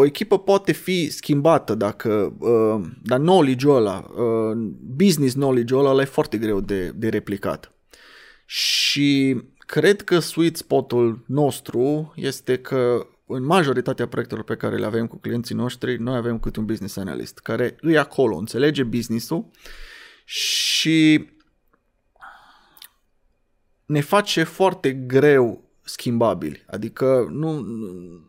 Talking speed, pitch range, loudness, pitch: 120 wpm, 115-155 Hz, -21 LUFS, 130 Hz